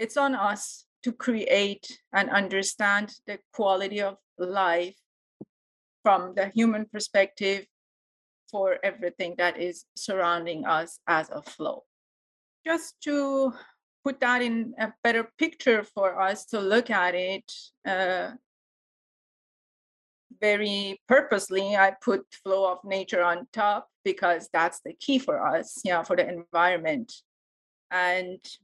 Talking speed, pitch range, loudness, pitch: 130 wpm, 185-235 Hz, -26 LUFS, 200 Hz